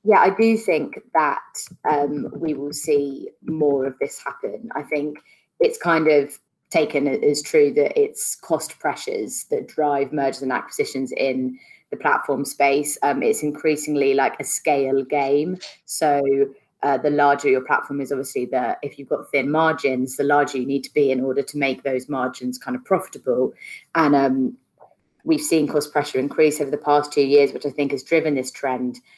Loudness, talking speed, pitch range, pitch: -21 LUFS, 185 wpm, 135-150 Hz, 145 Hz